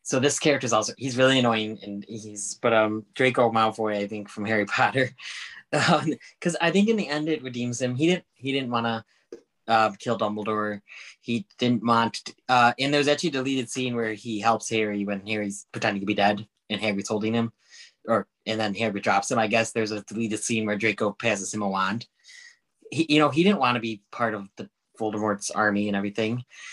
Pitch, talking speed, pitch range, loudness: 115 Hz, 210 wpm, 105-130 Hz, -25 LUFS